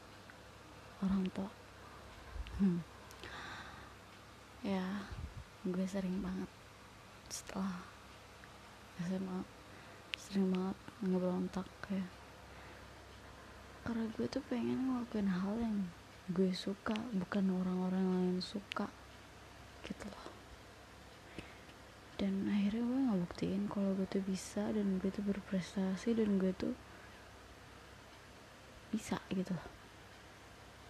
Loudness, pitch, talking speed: -39 LUFS, 185 Hz, 90 wpm